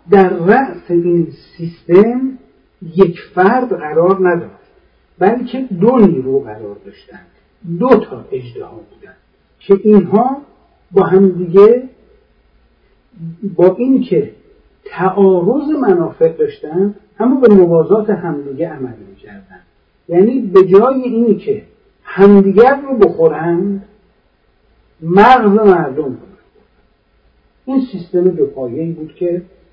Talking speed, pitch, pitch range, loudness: 100 wpm, 195 Hz, 175-230 Hz, -12 LUFS